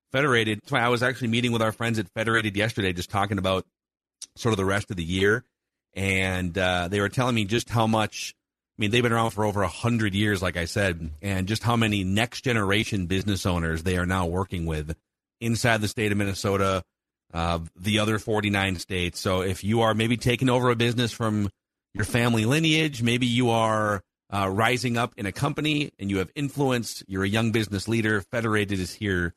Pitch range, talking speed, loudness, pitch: 95-115 Hz, 210 wpm, -25 LUFS, 105 Hz